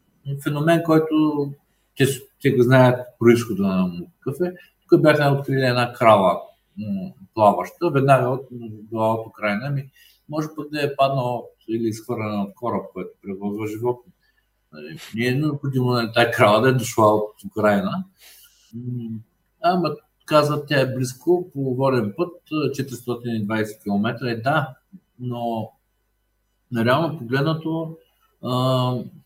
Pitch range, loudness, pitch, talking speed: 115-150 Hz, -21 LUFS, 130 Hz, 130 wpm